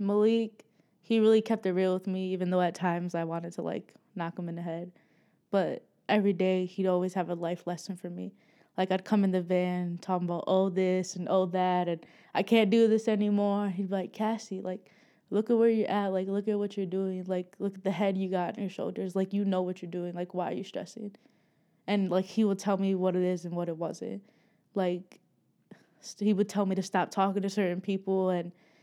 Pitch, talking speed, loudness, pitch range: 190 Hz, 235 wpm, -30 LUFS, 180-205 Hz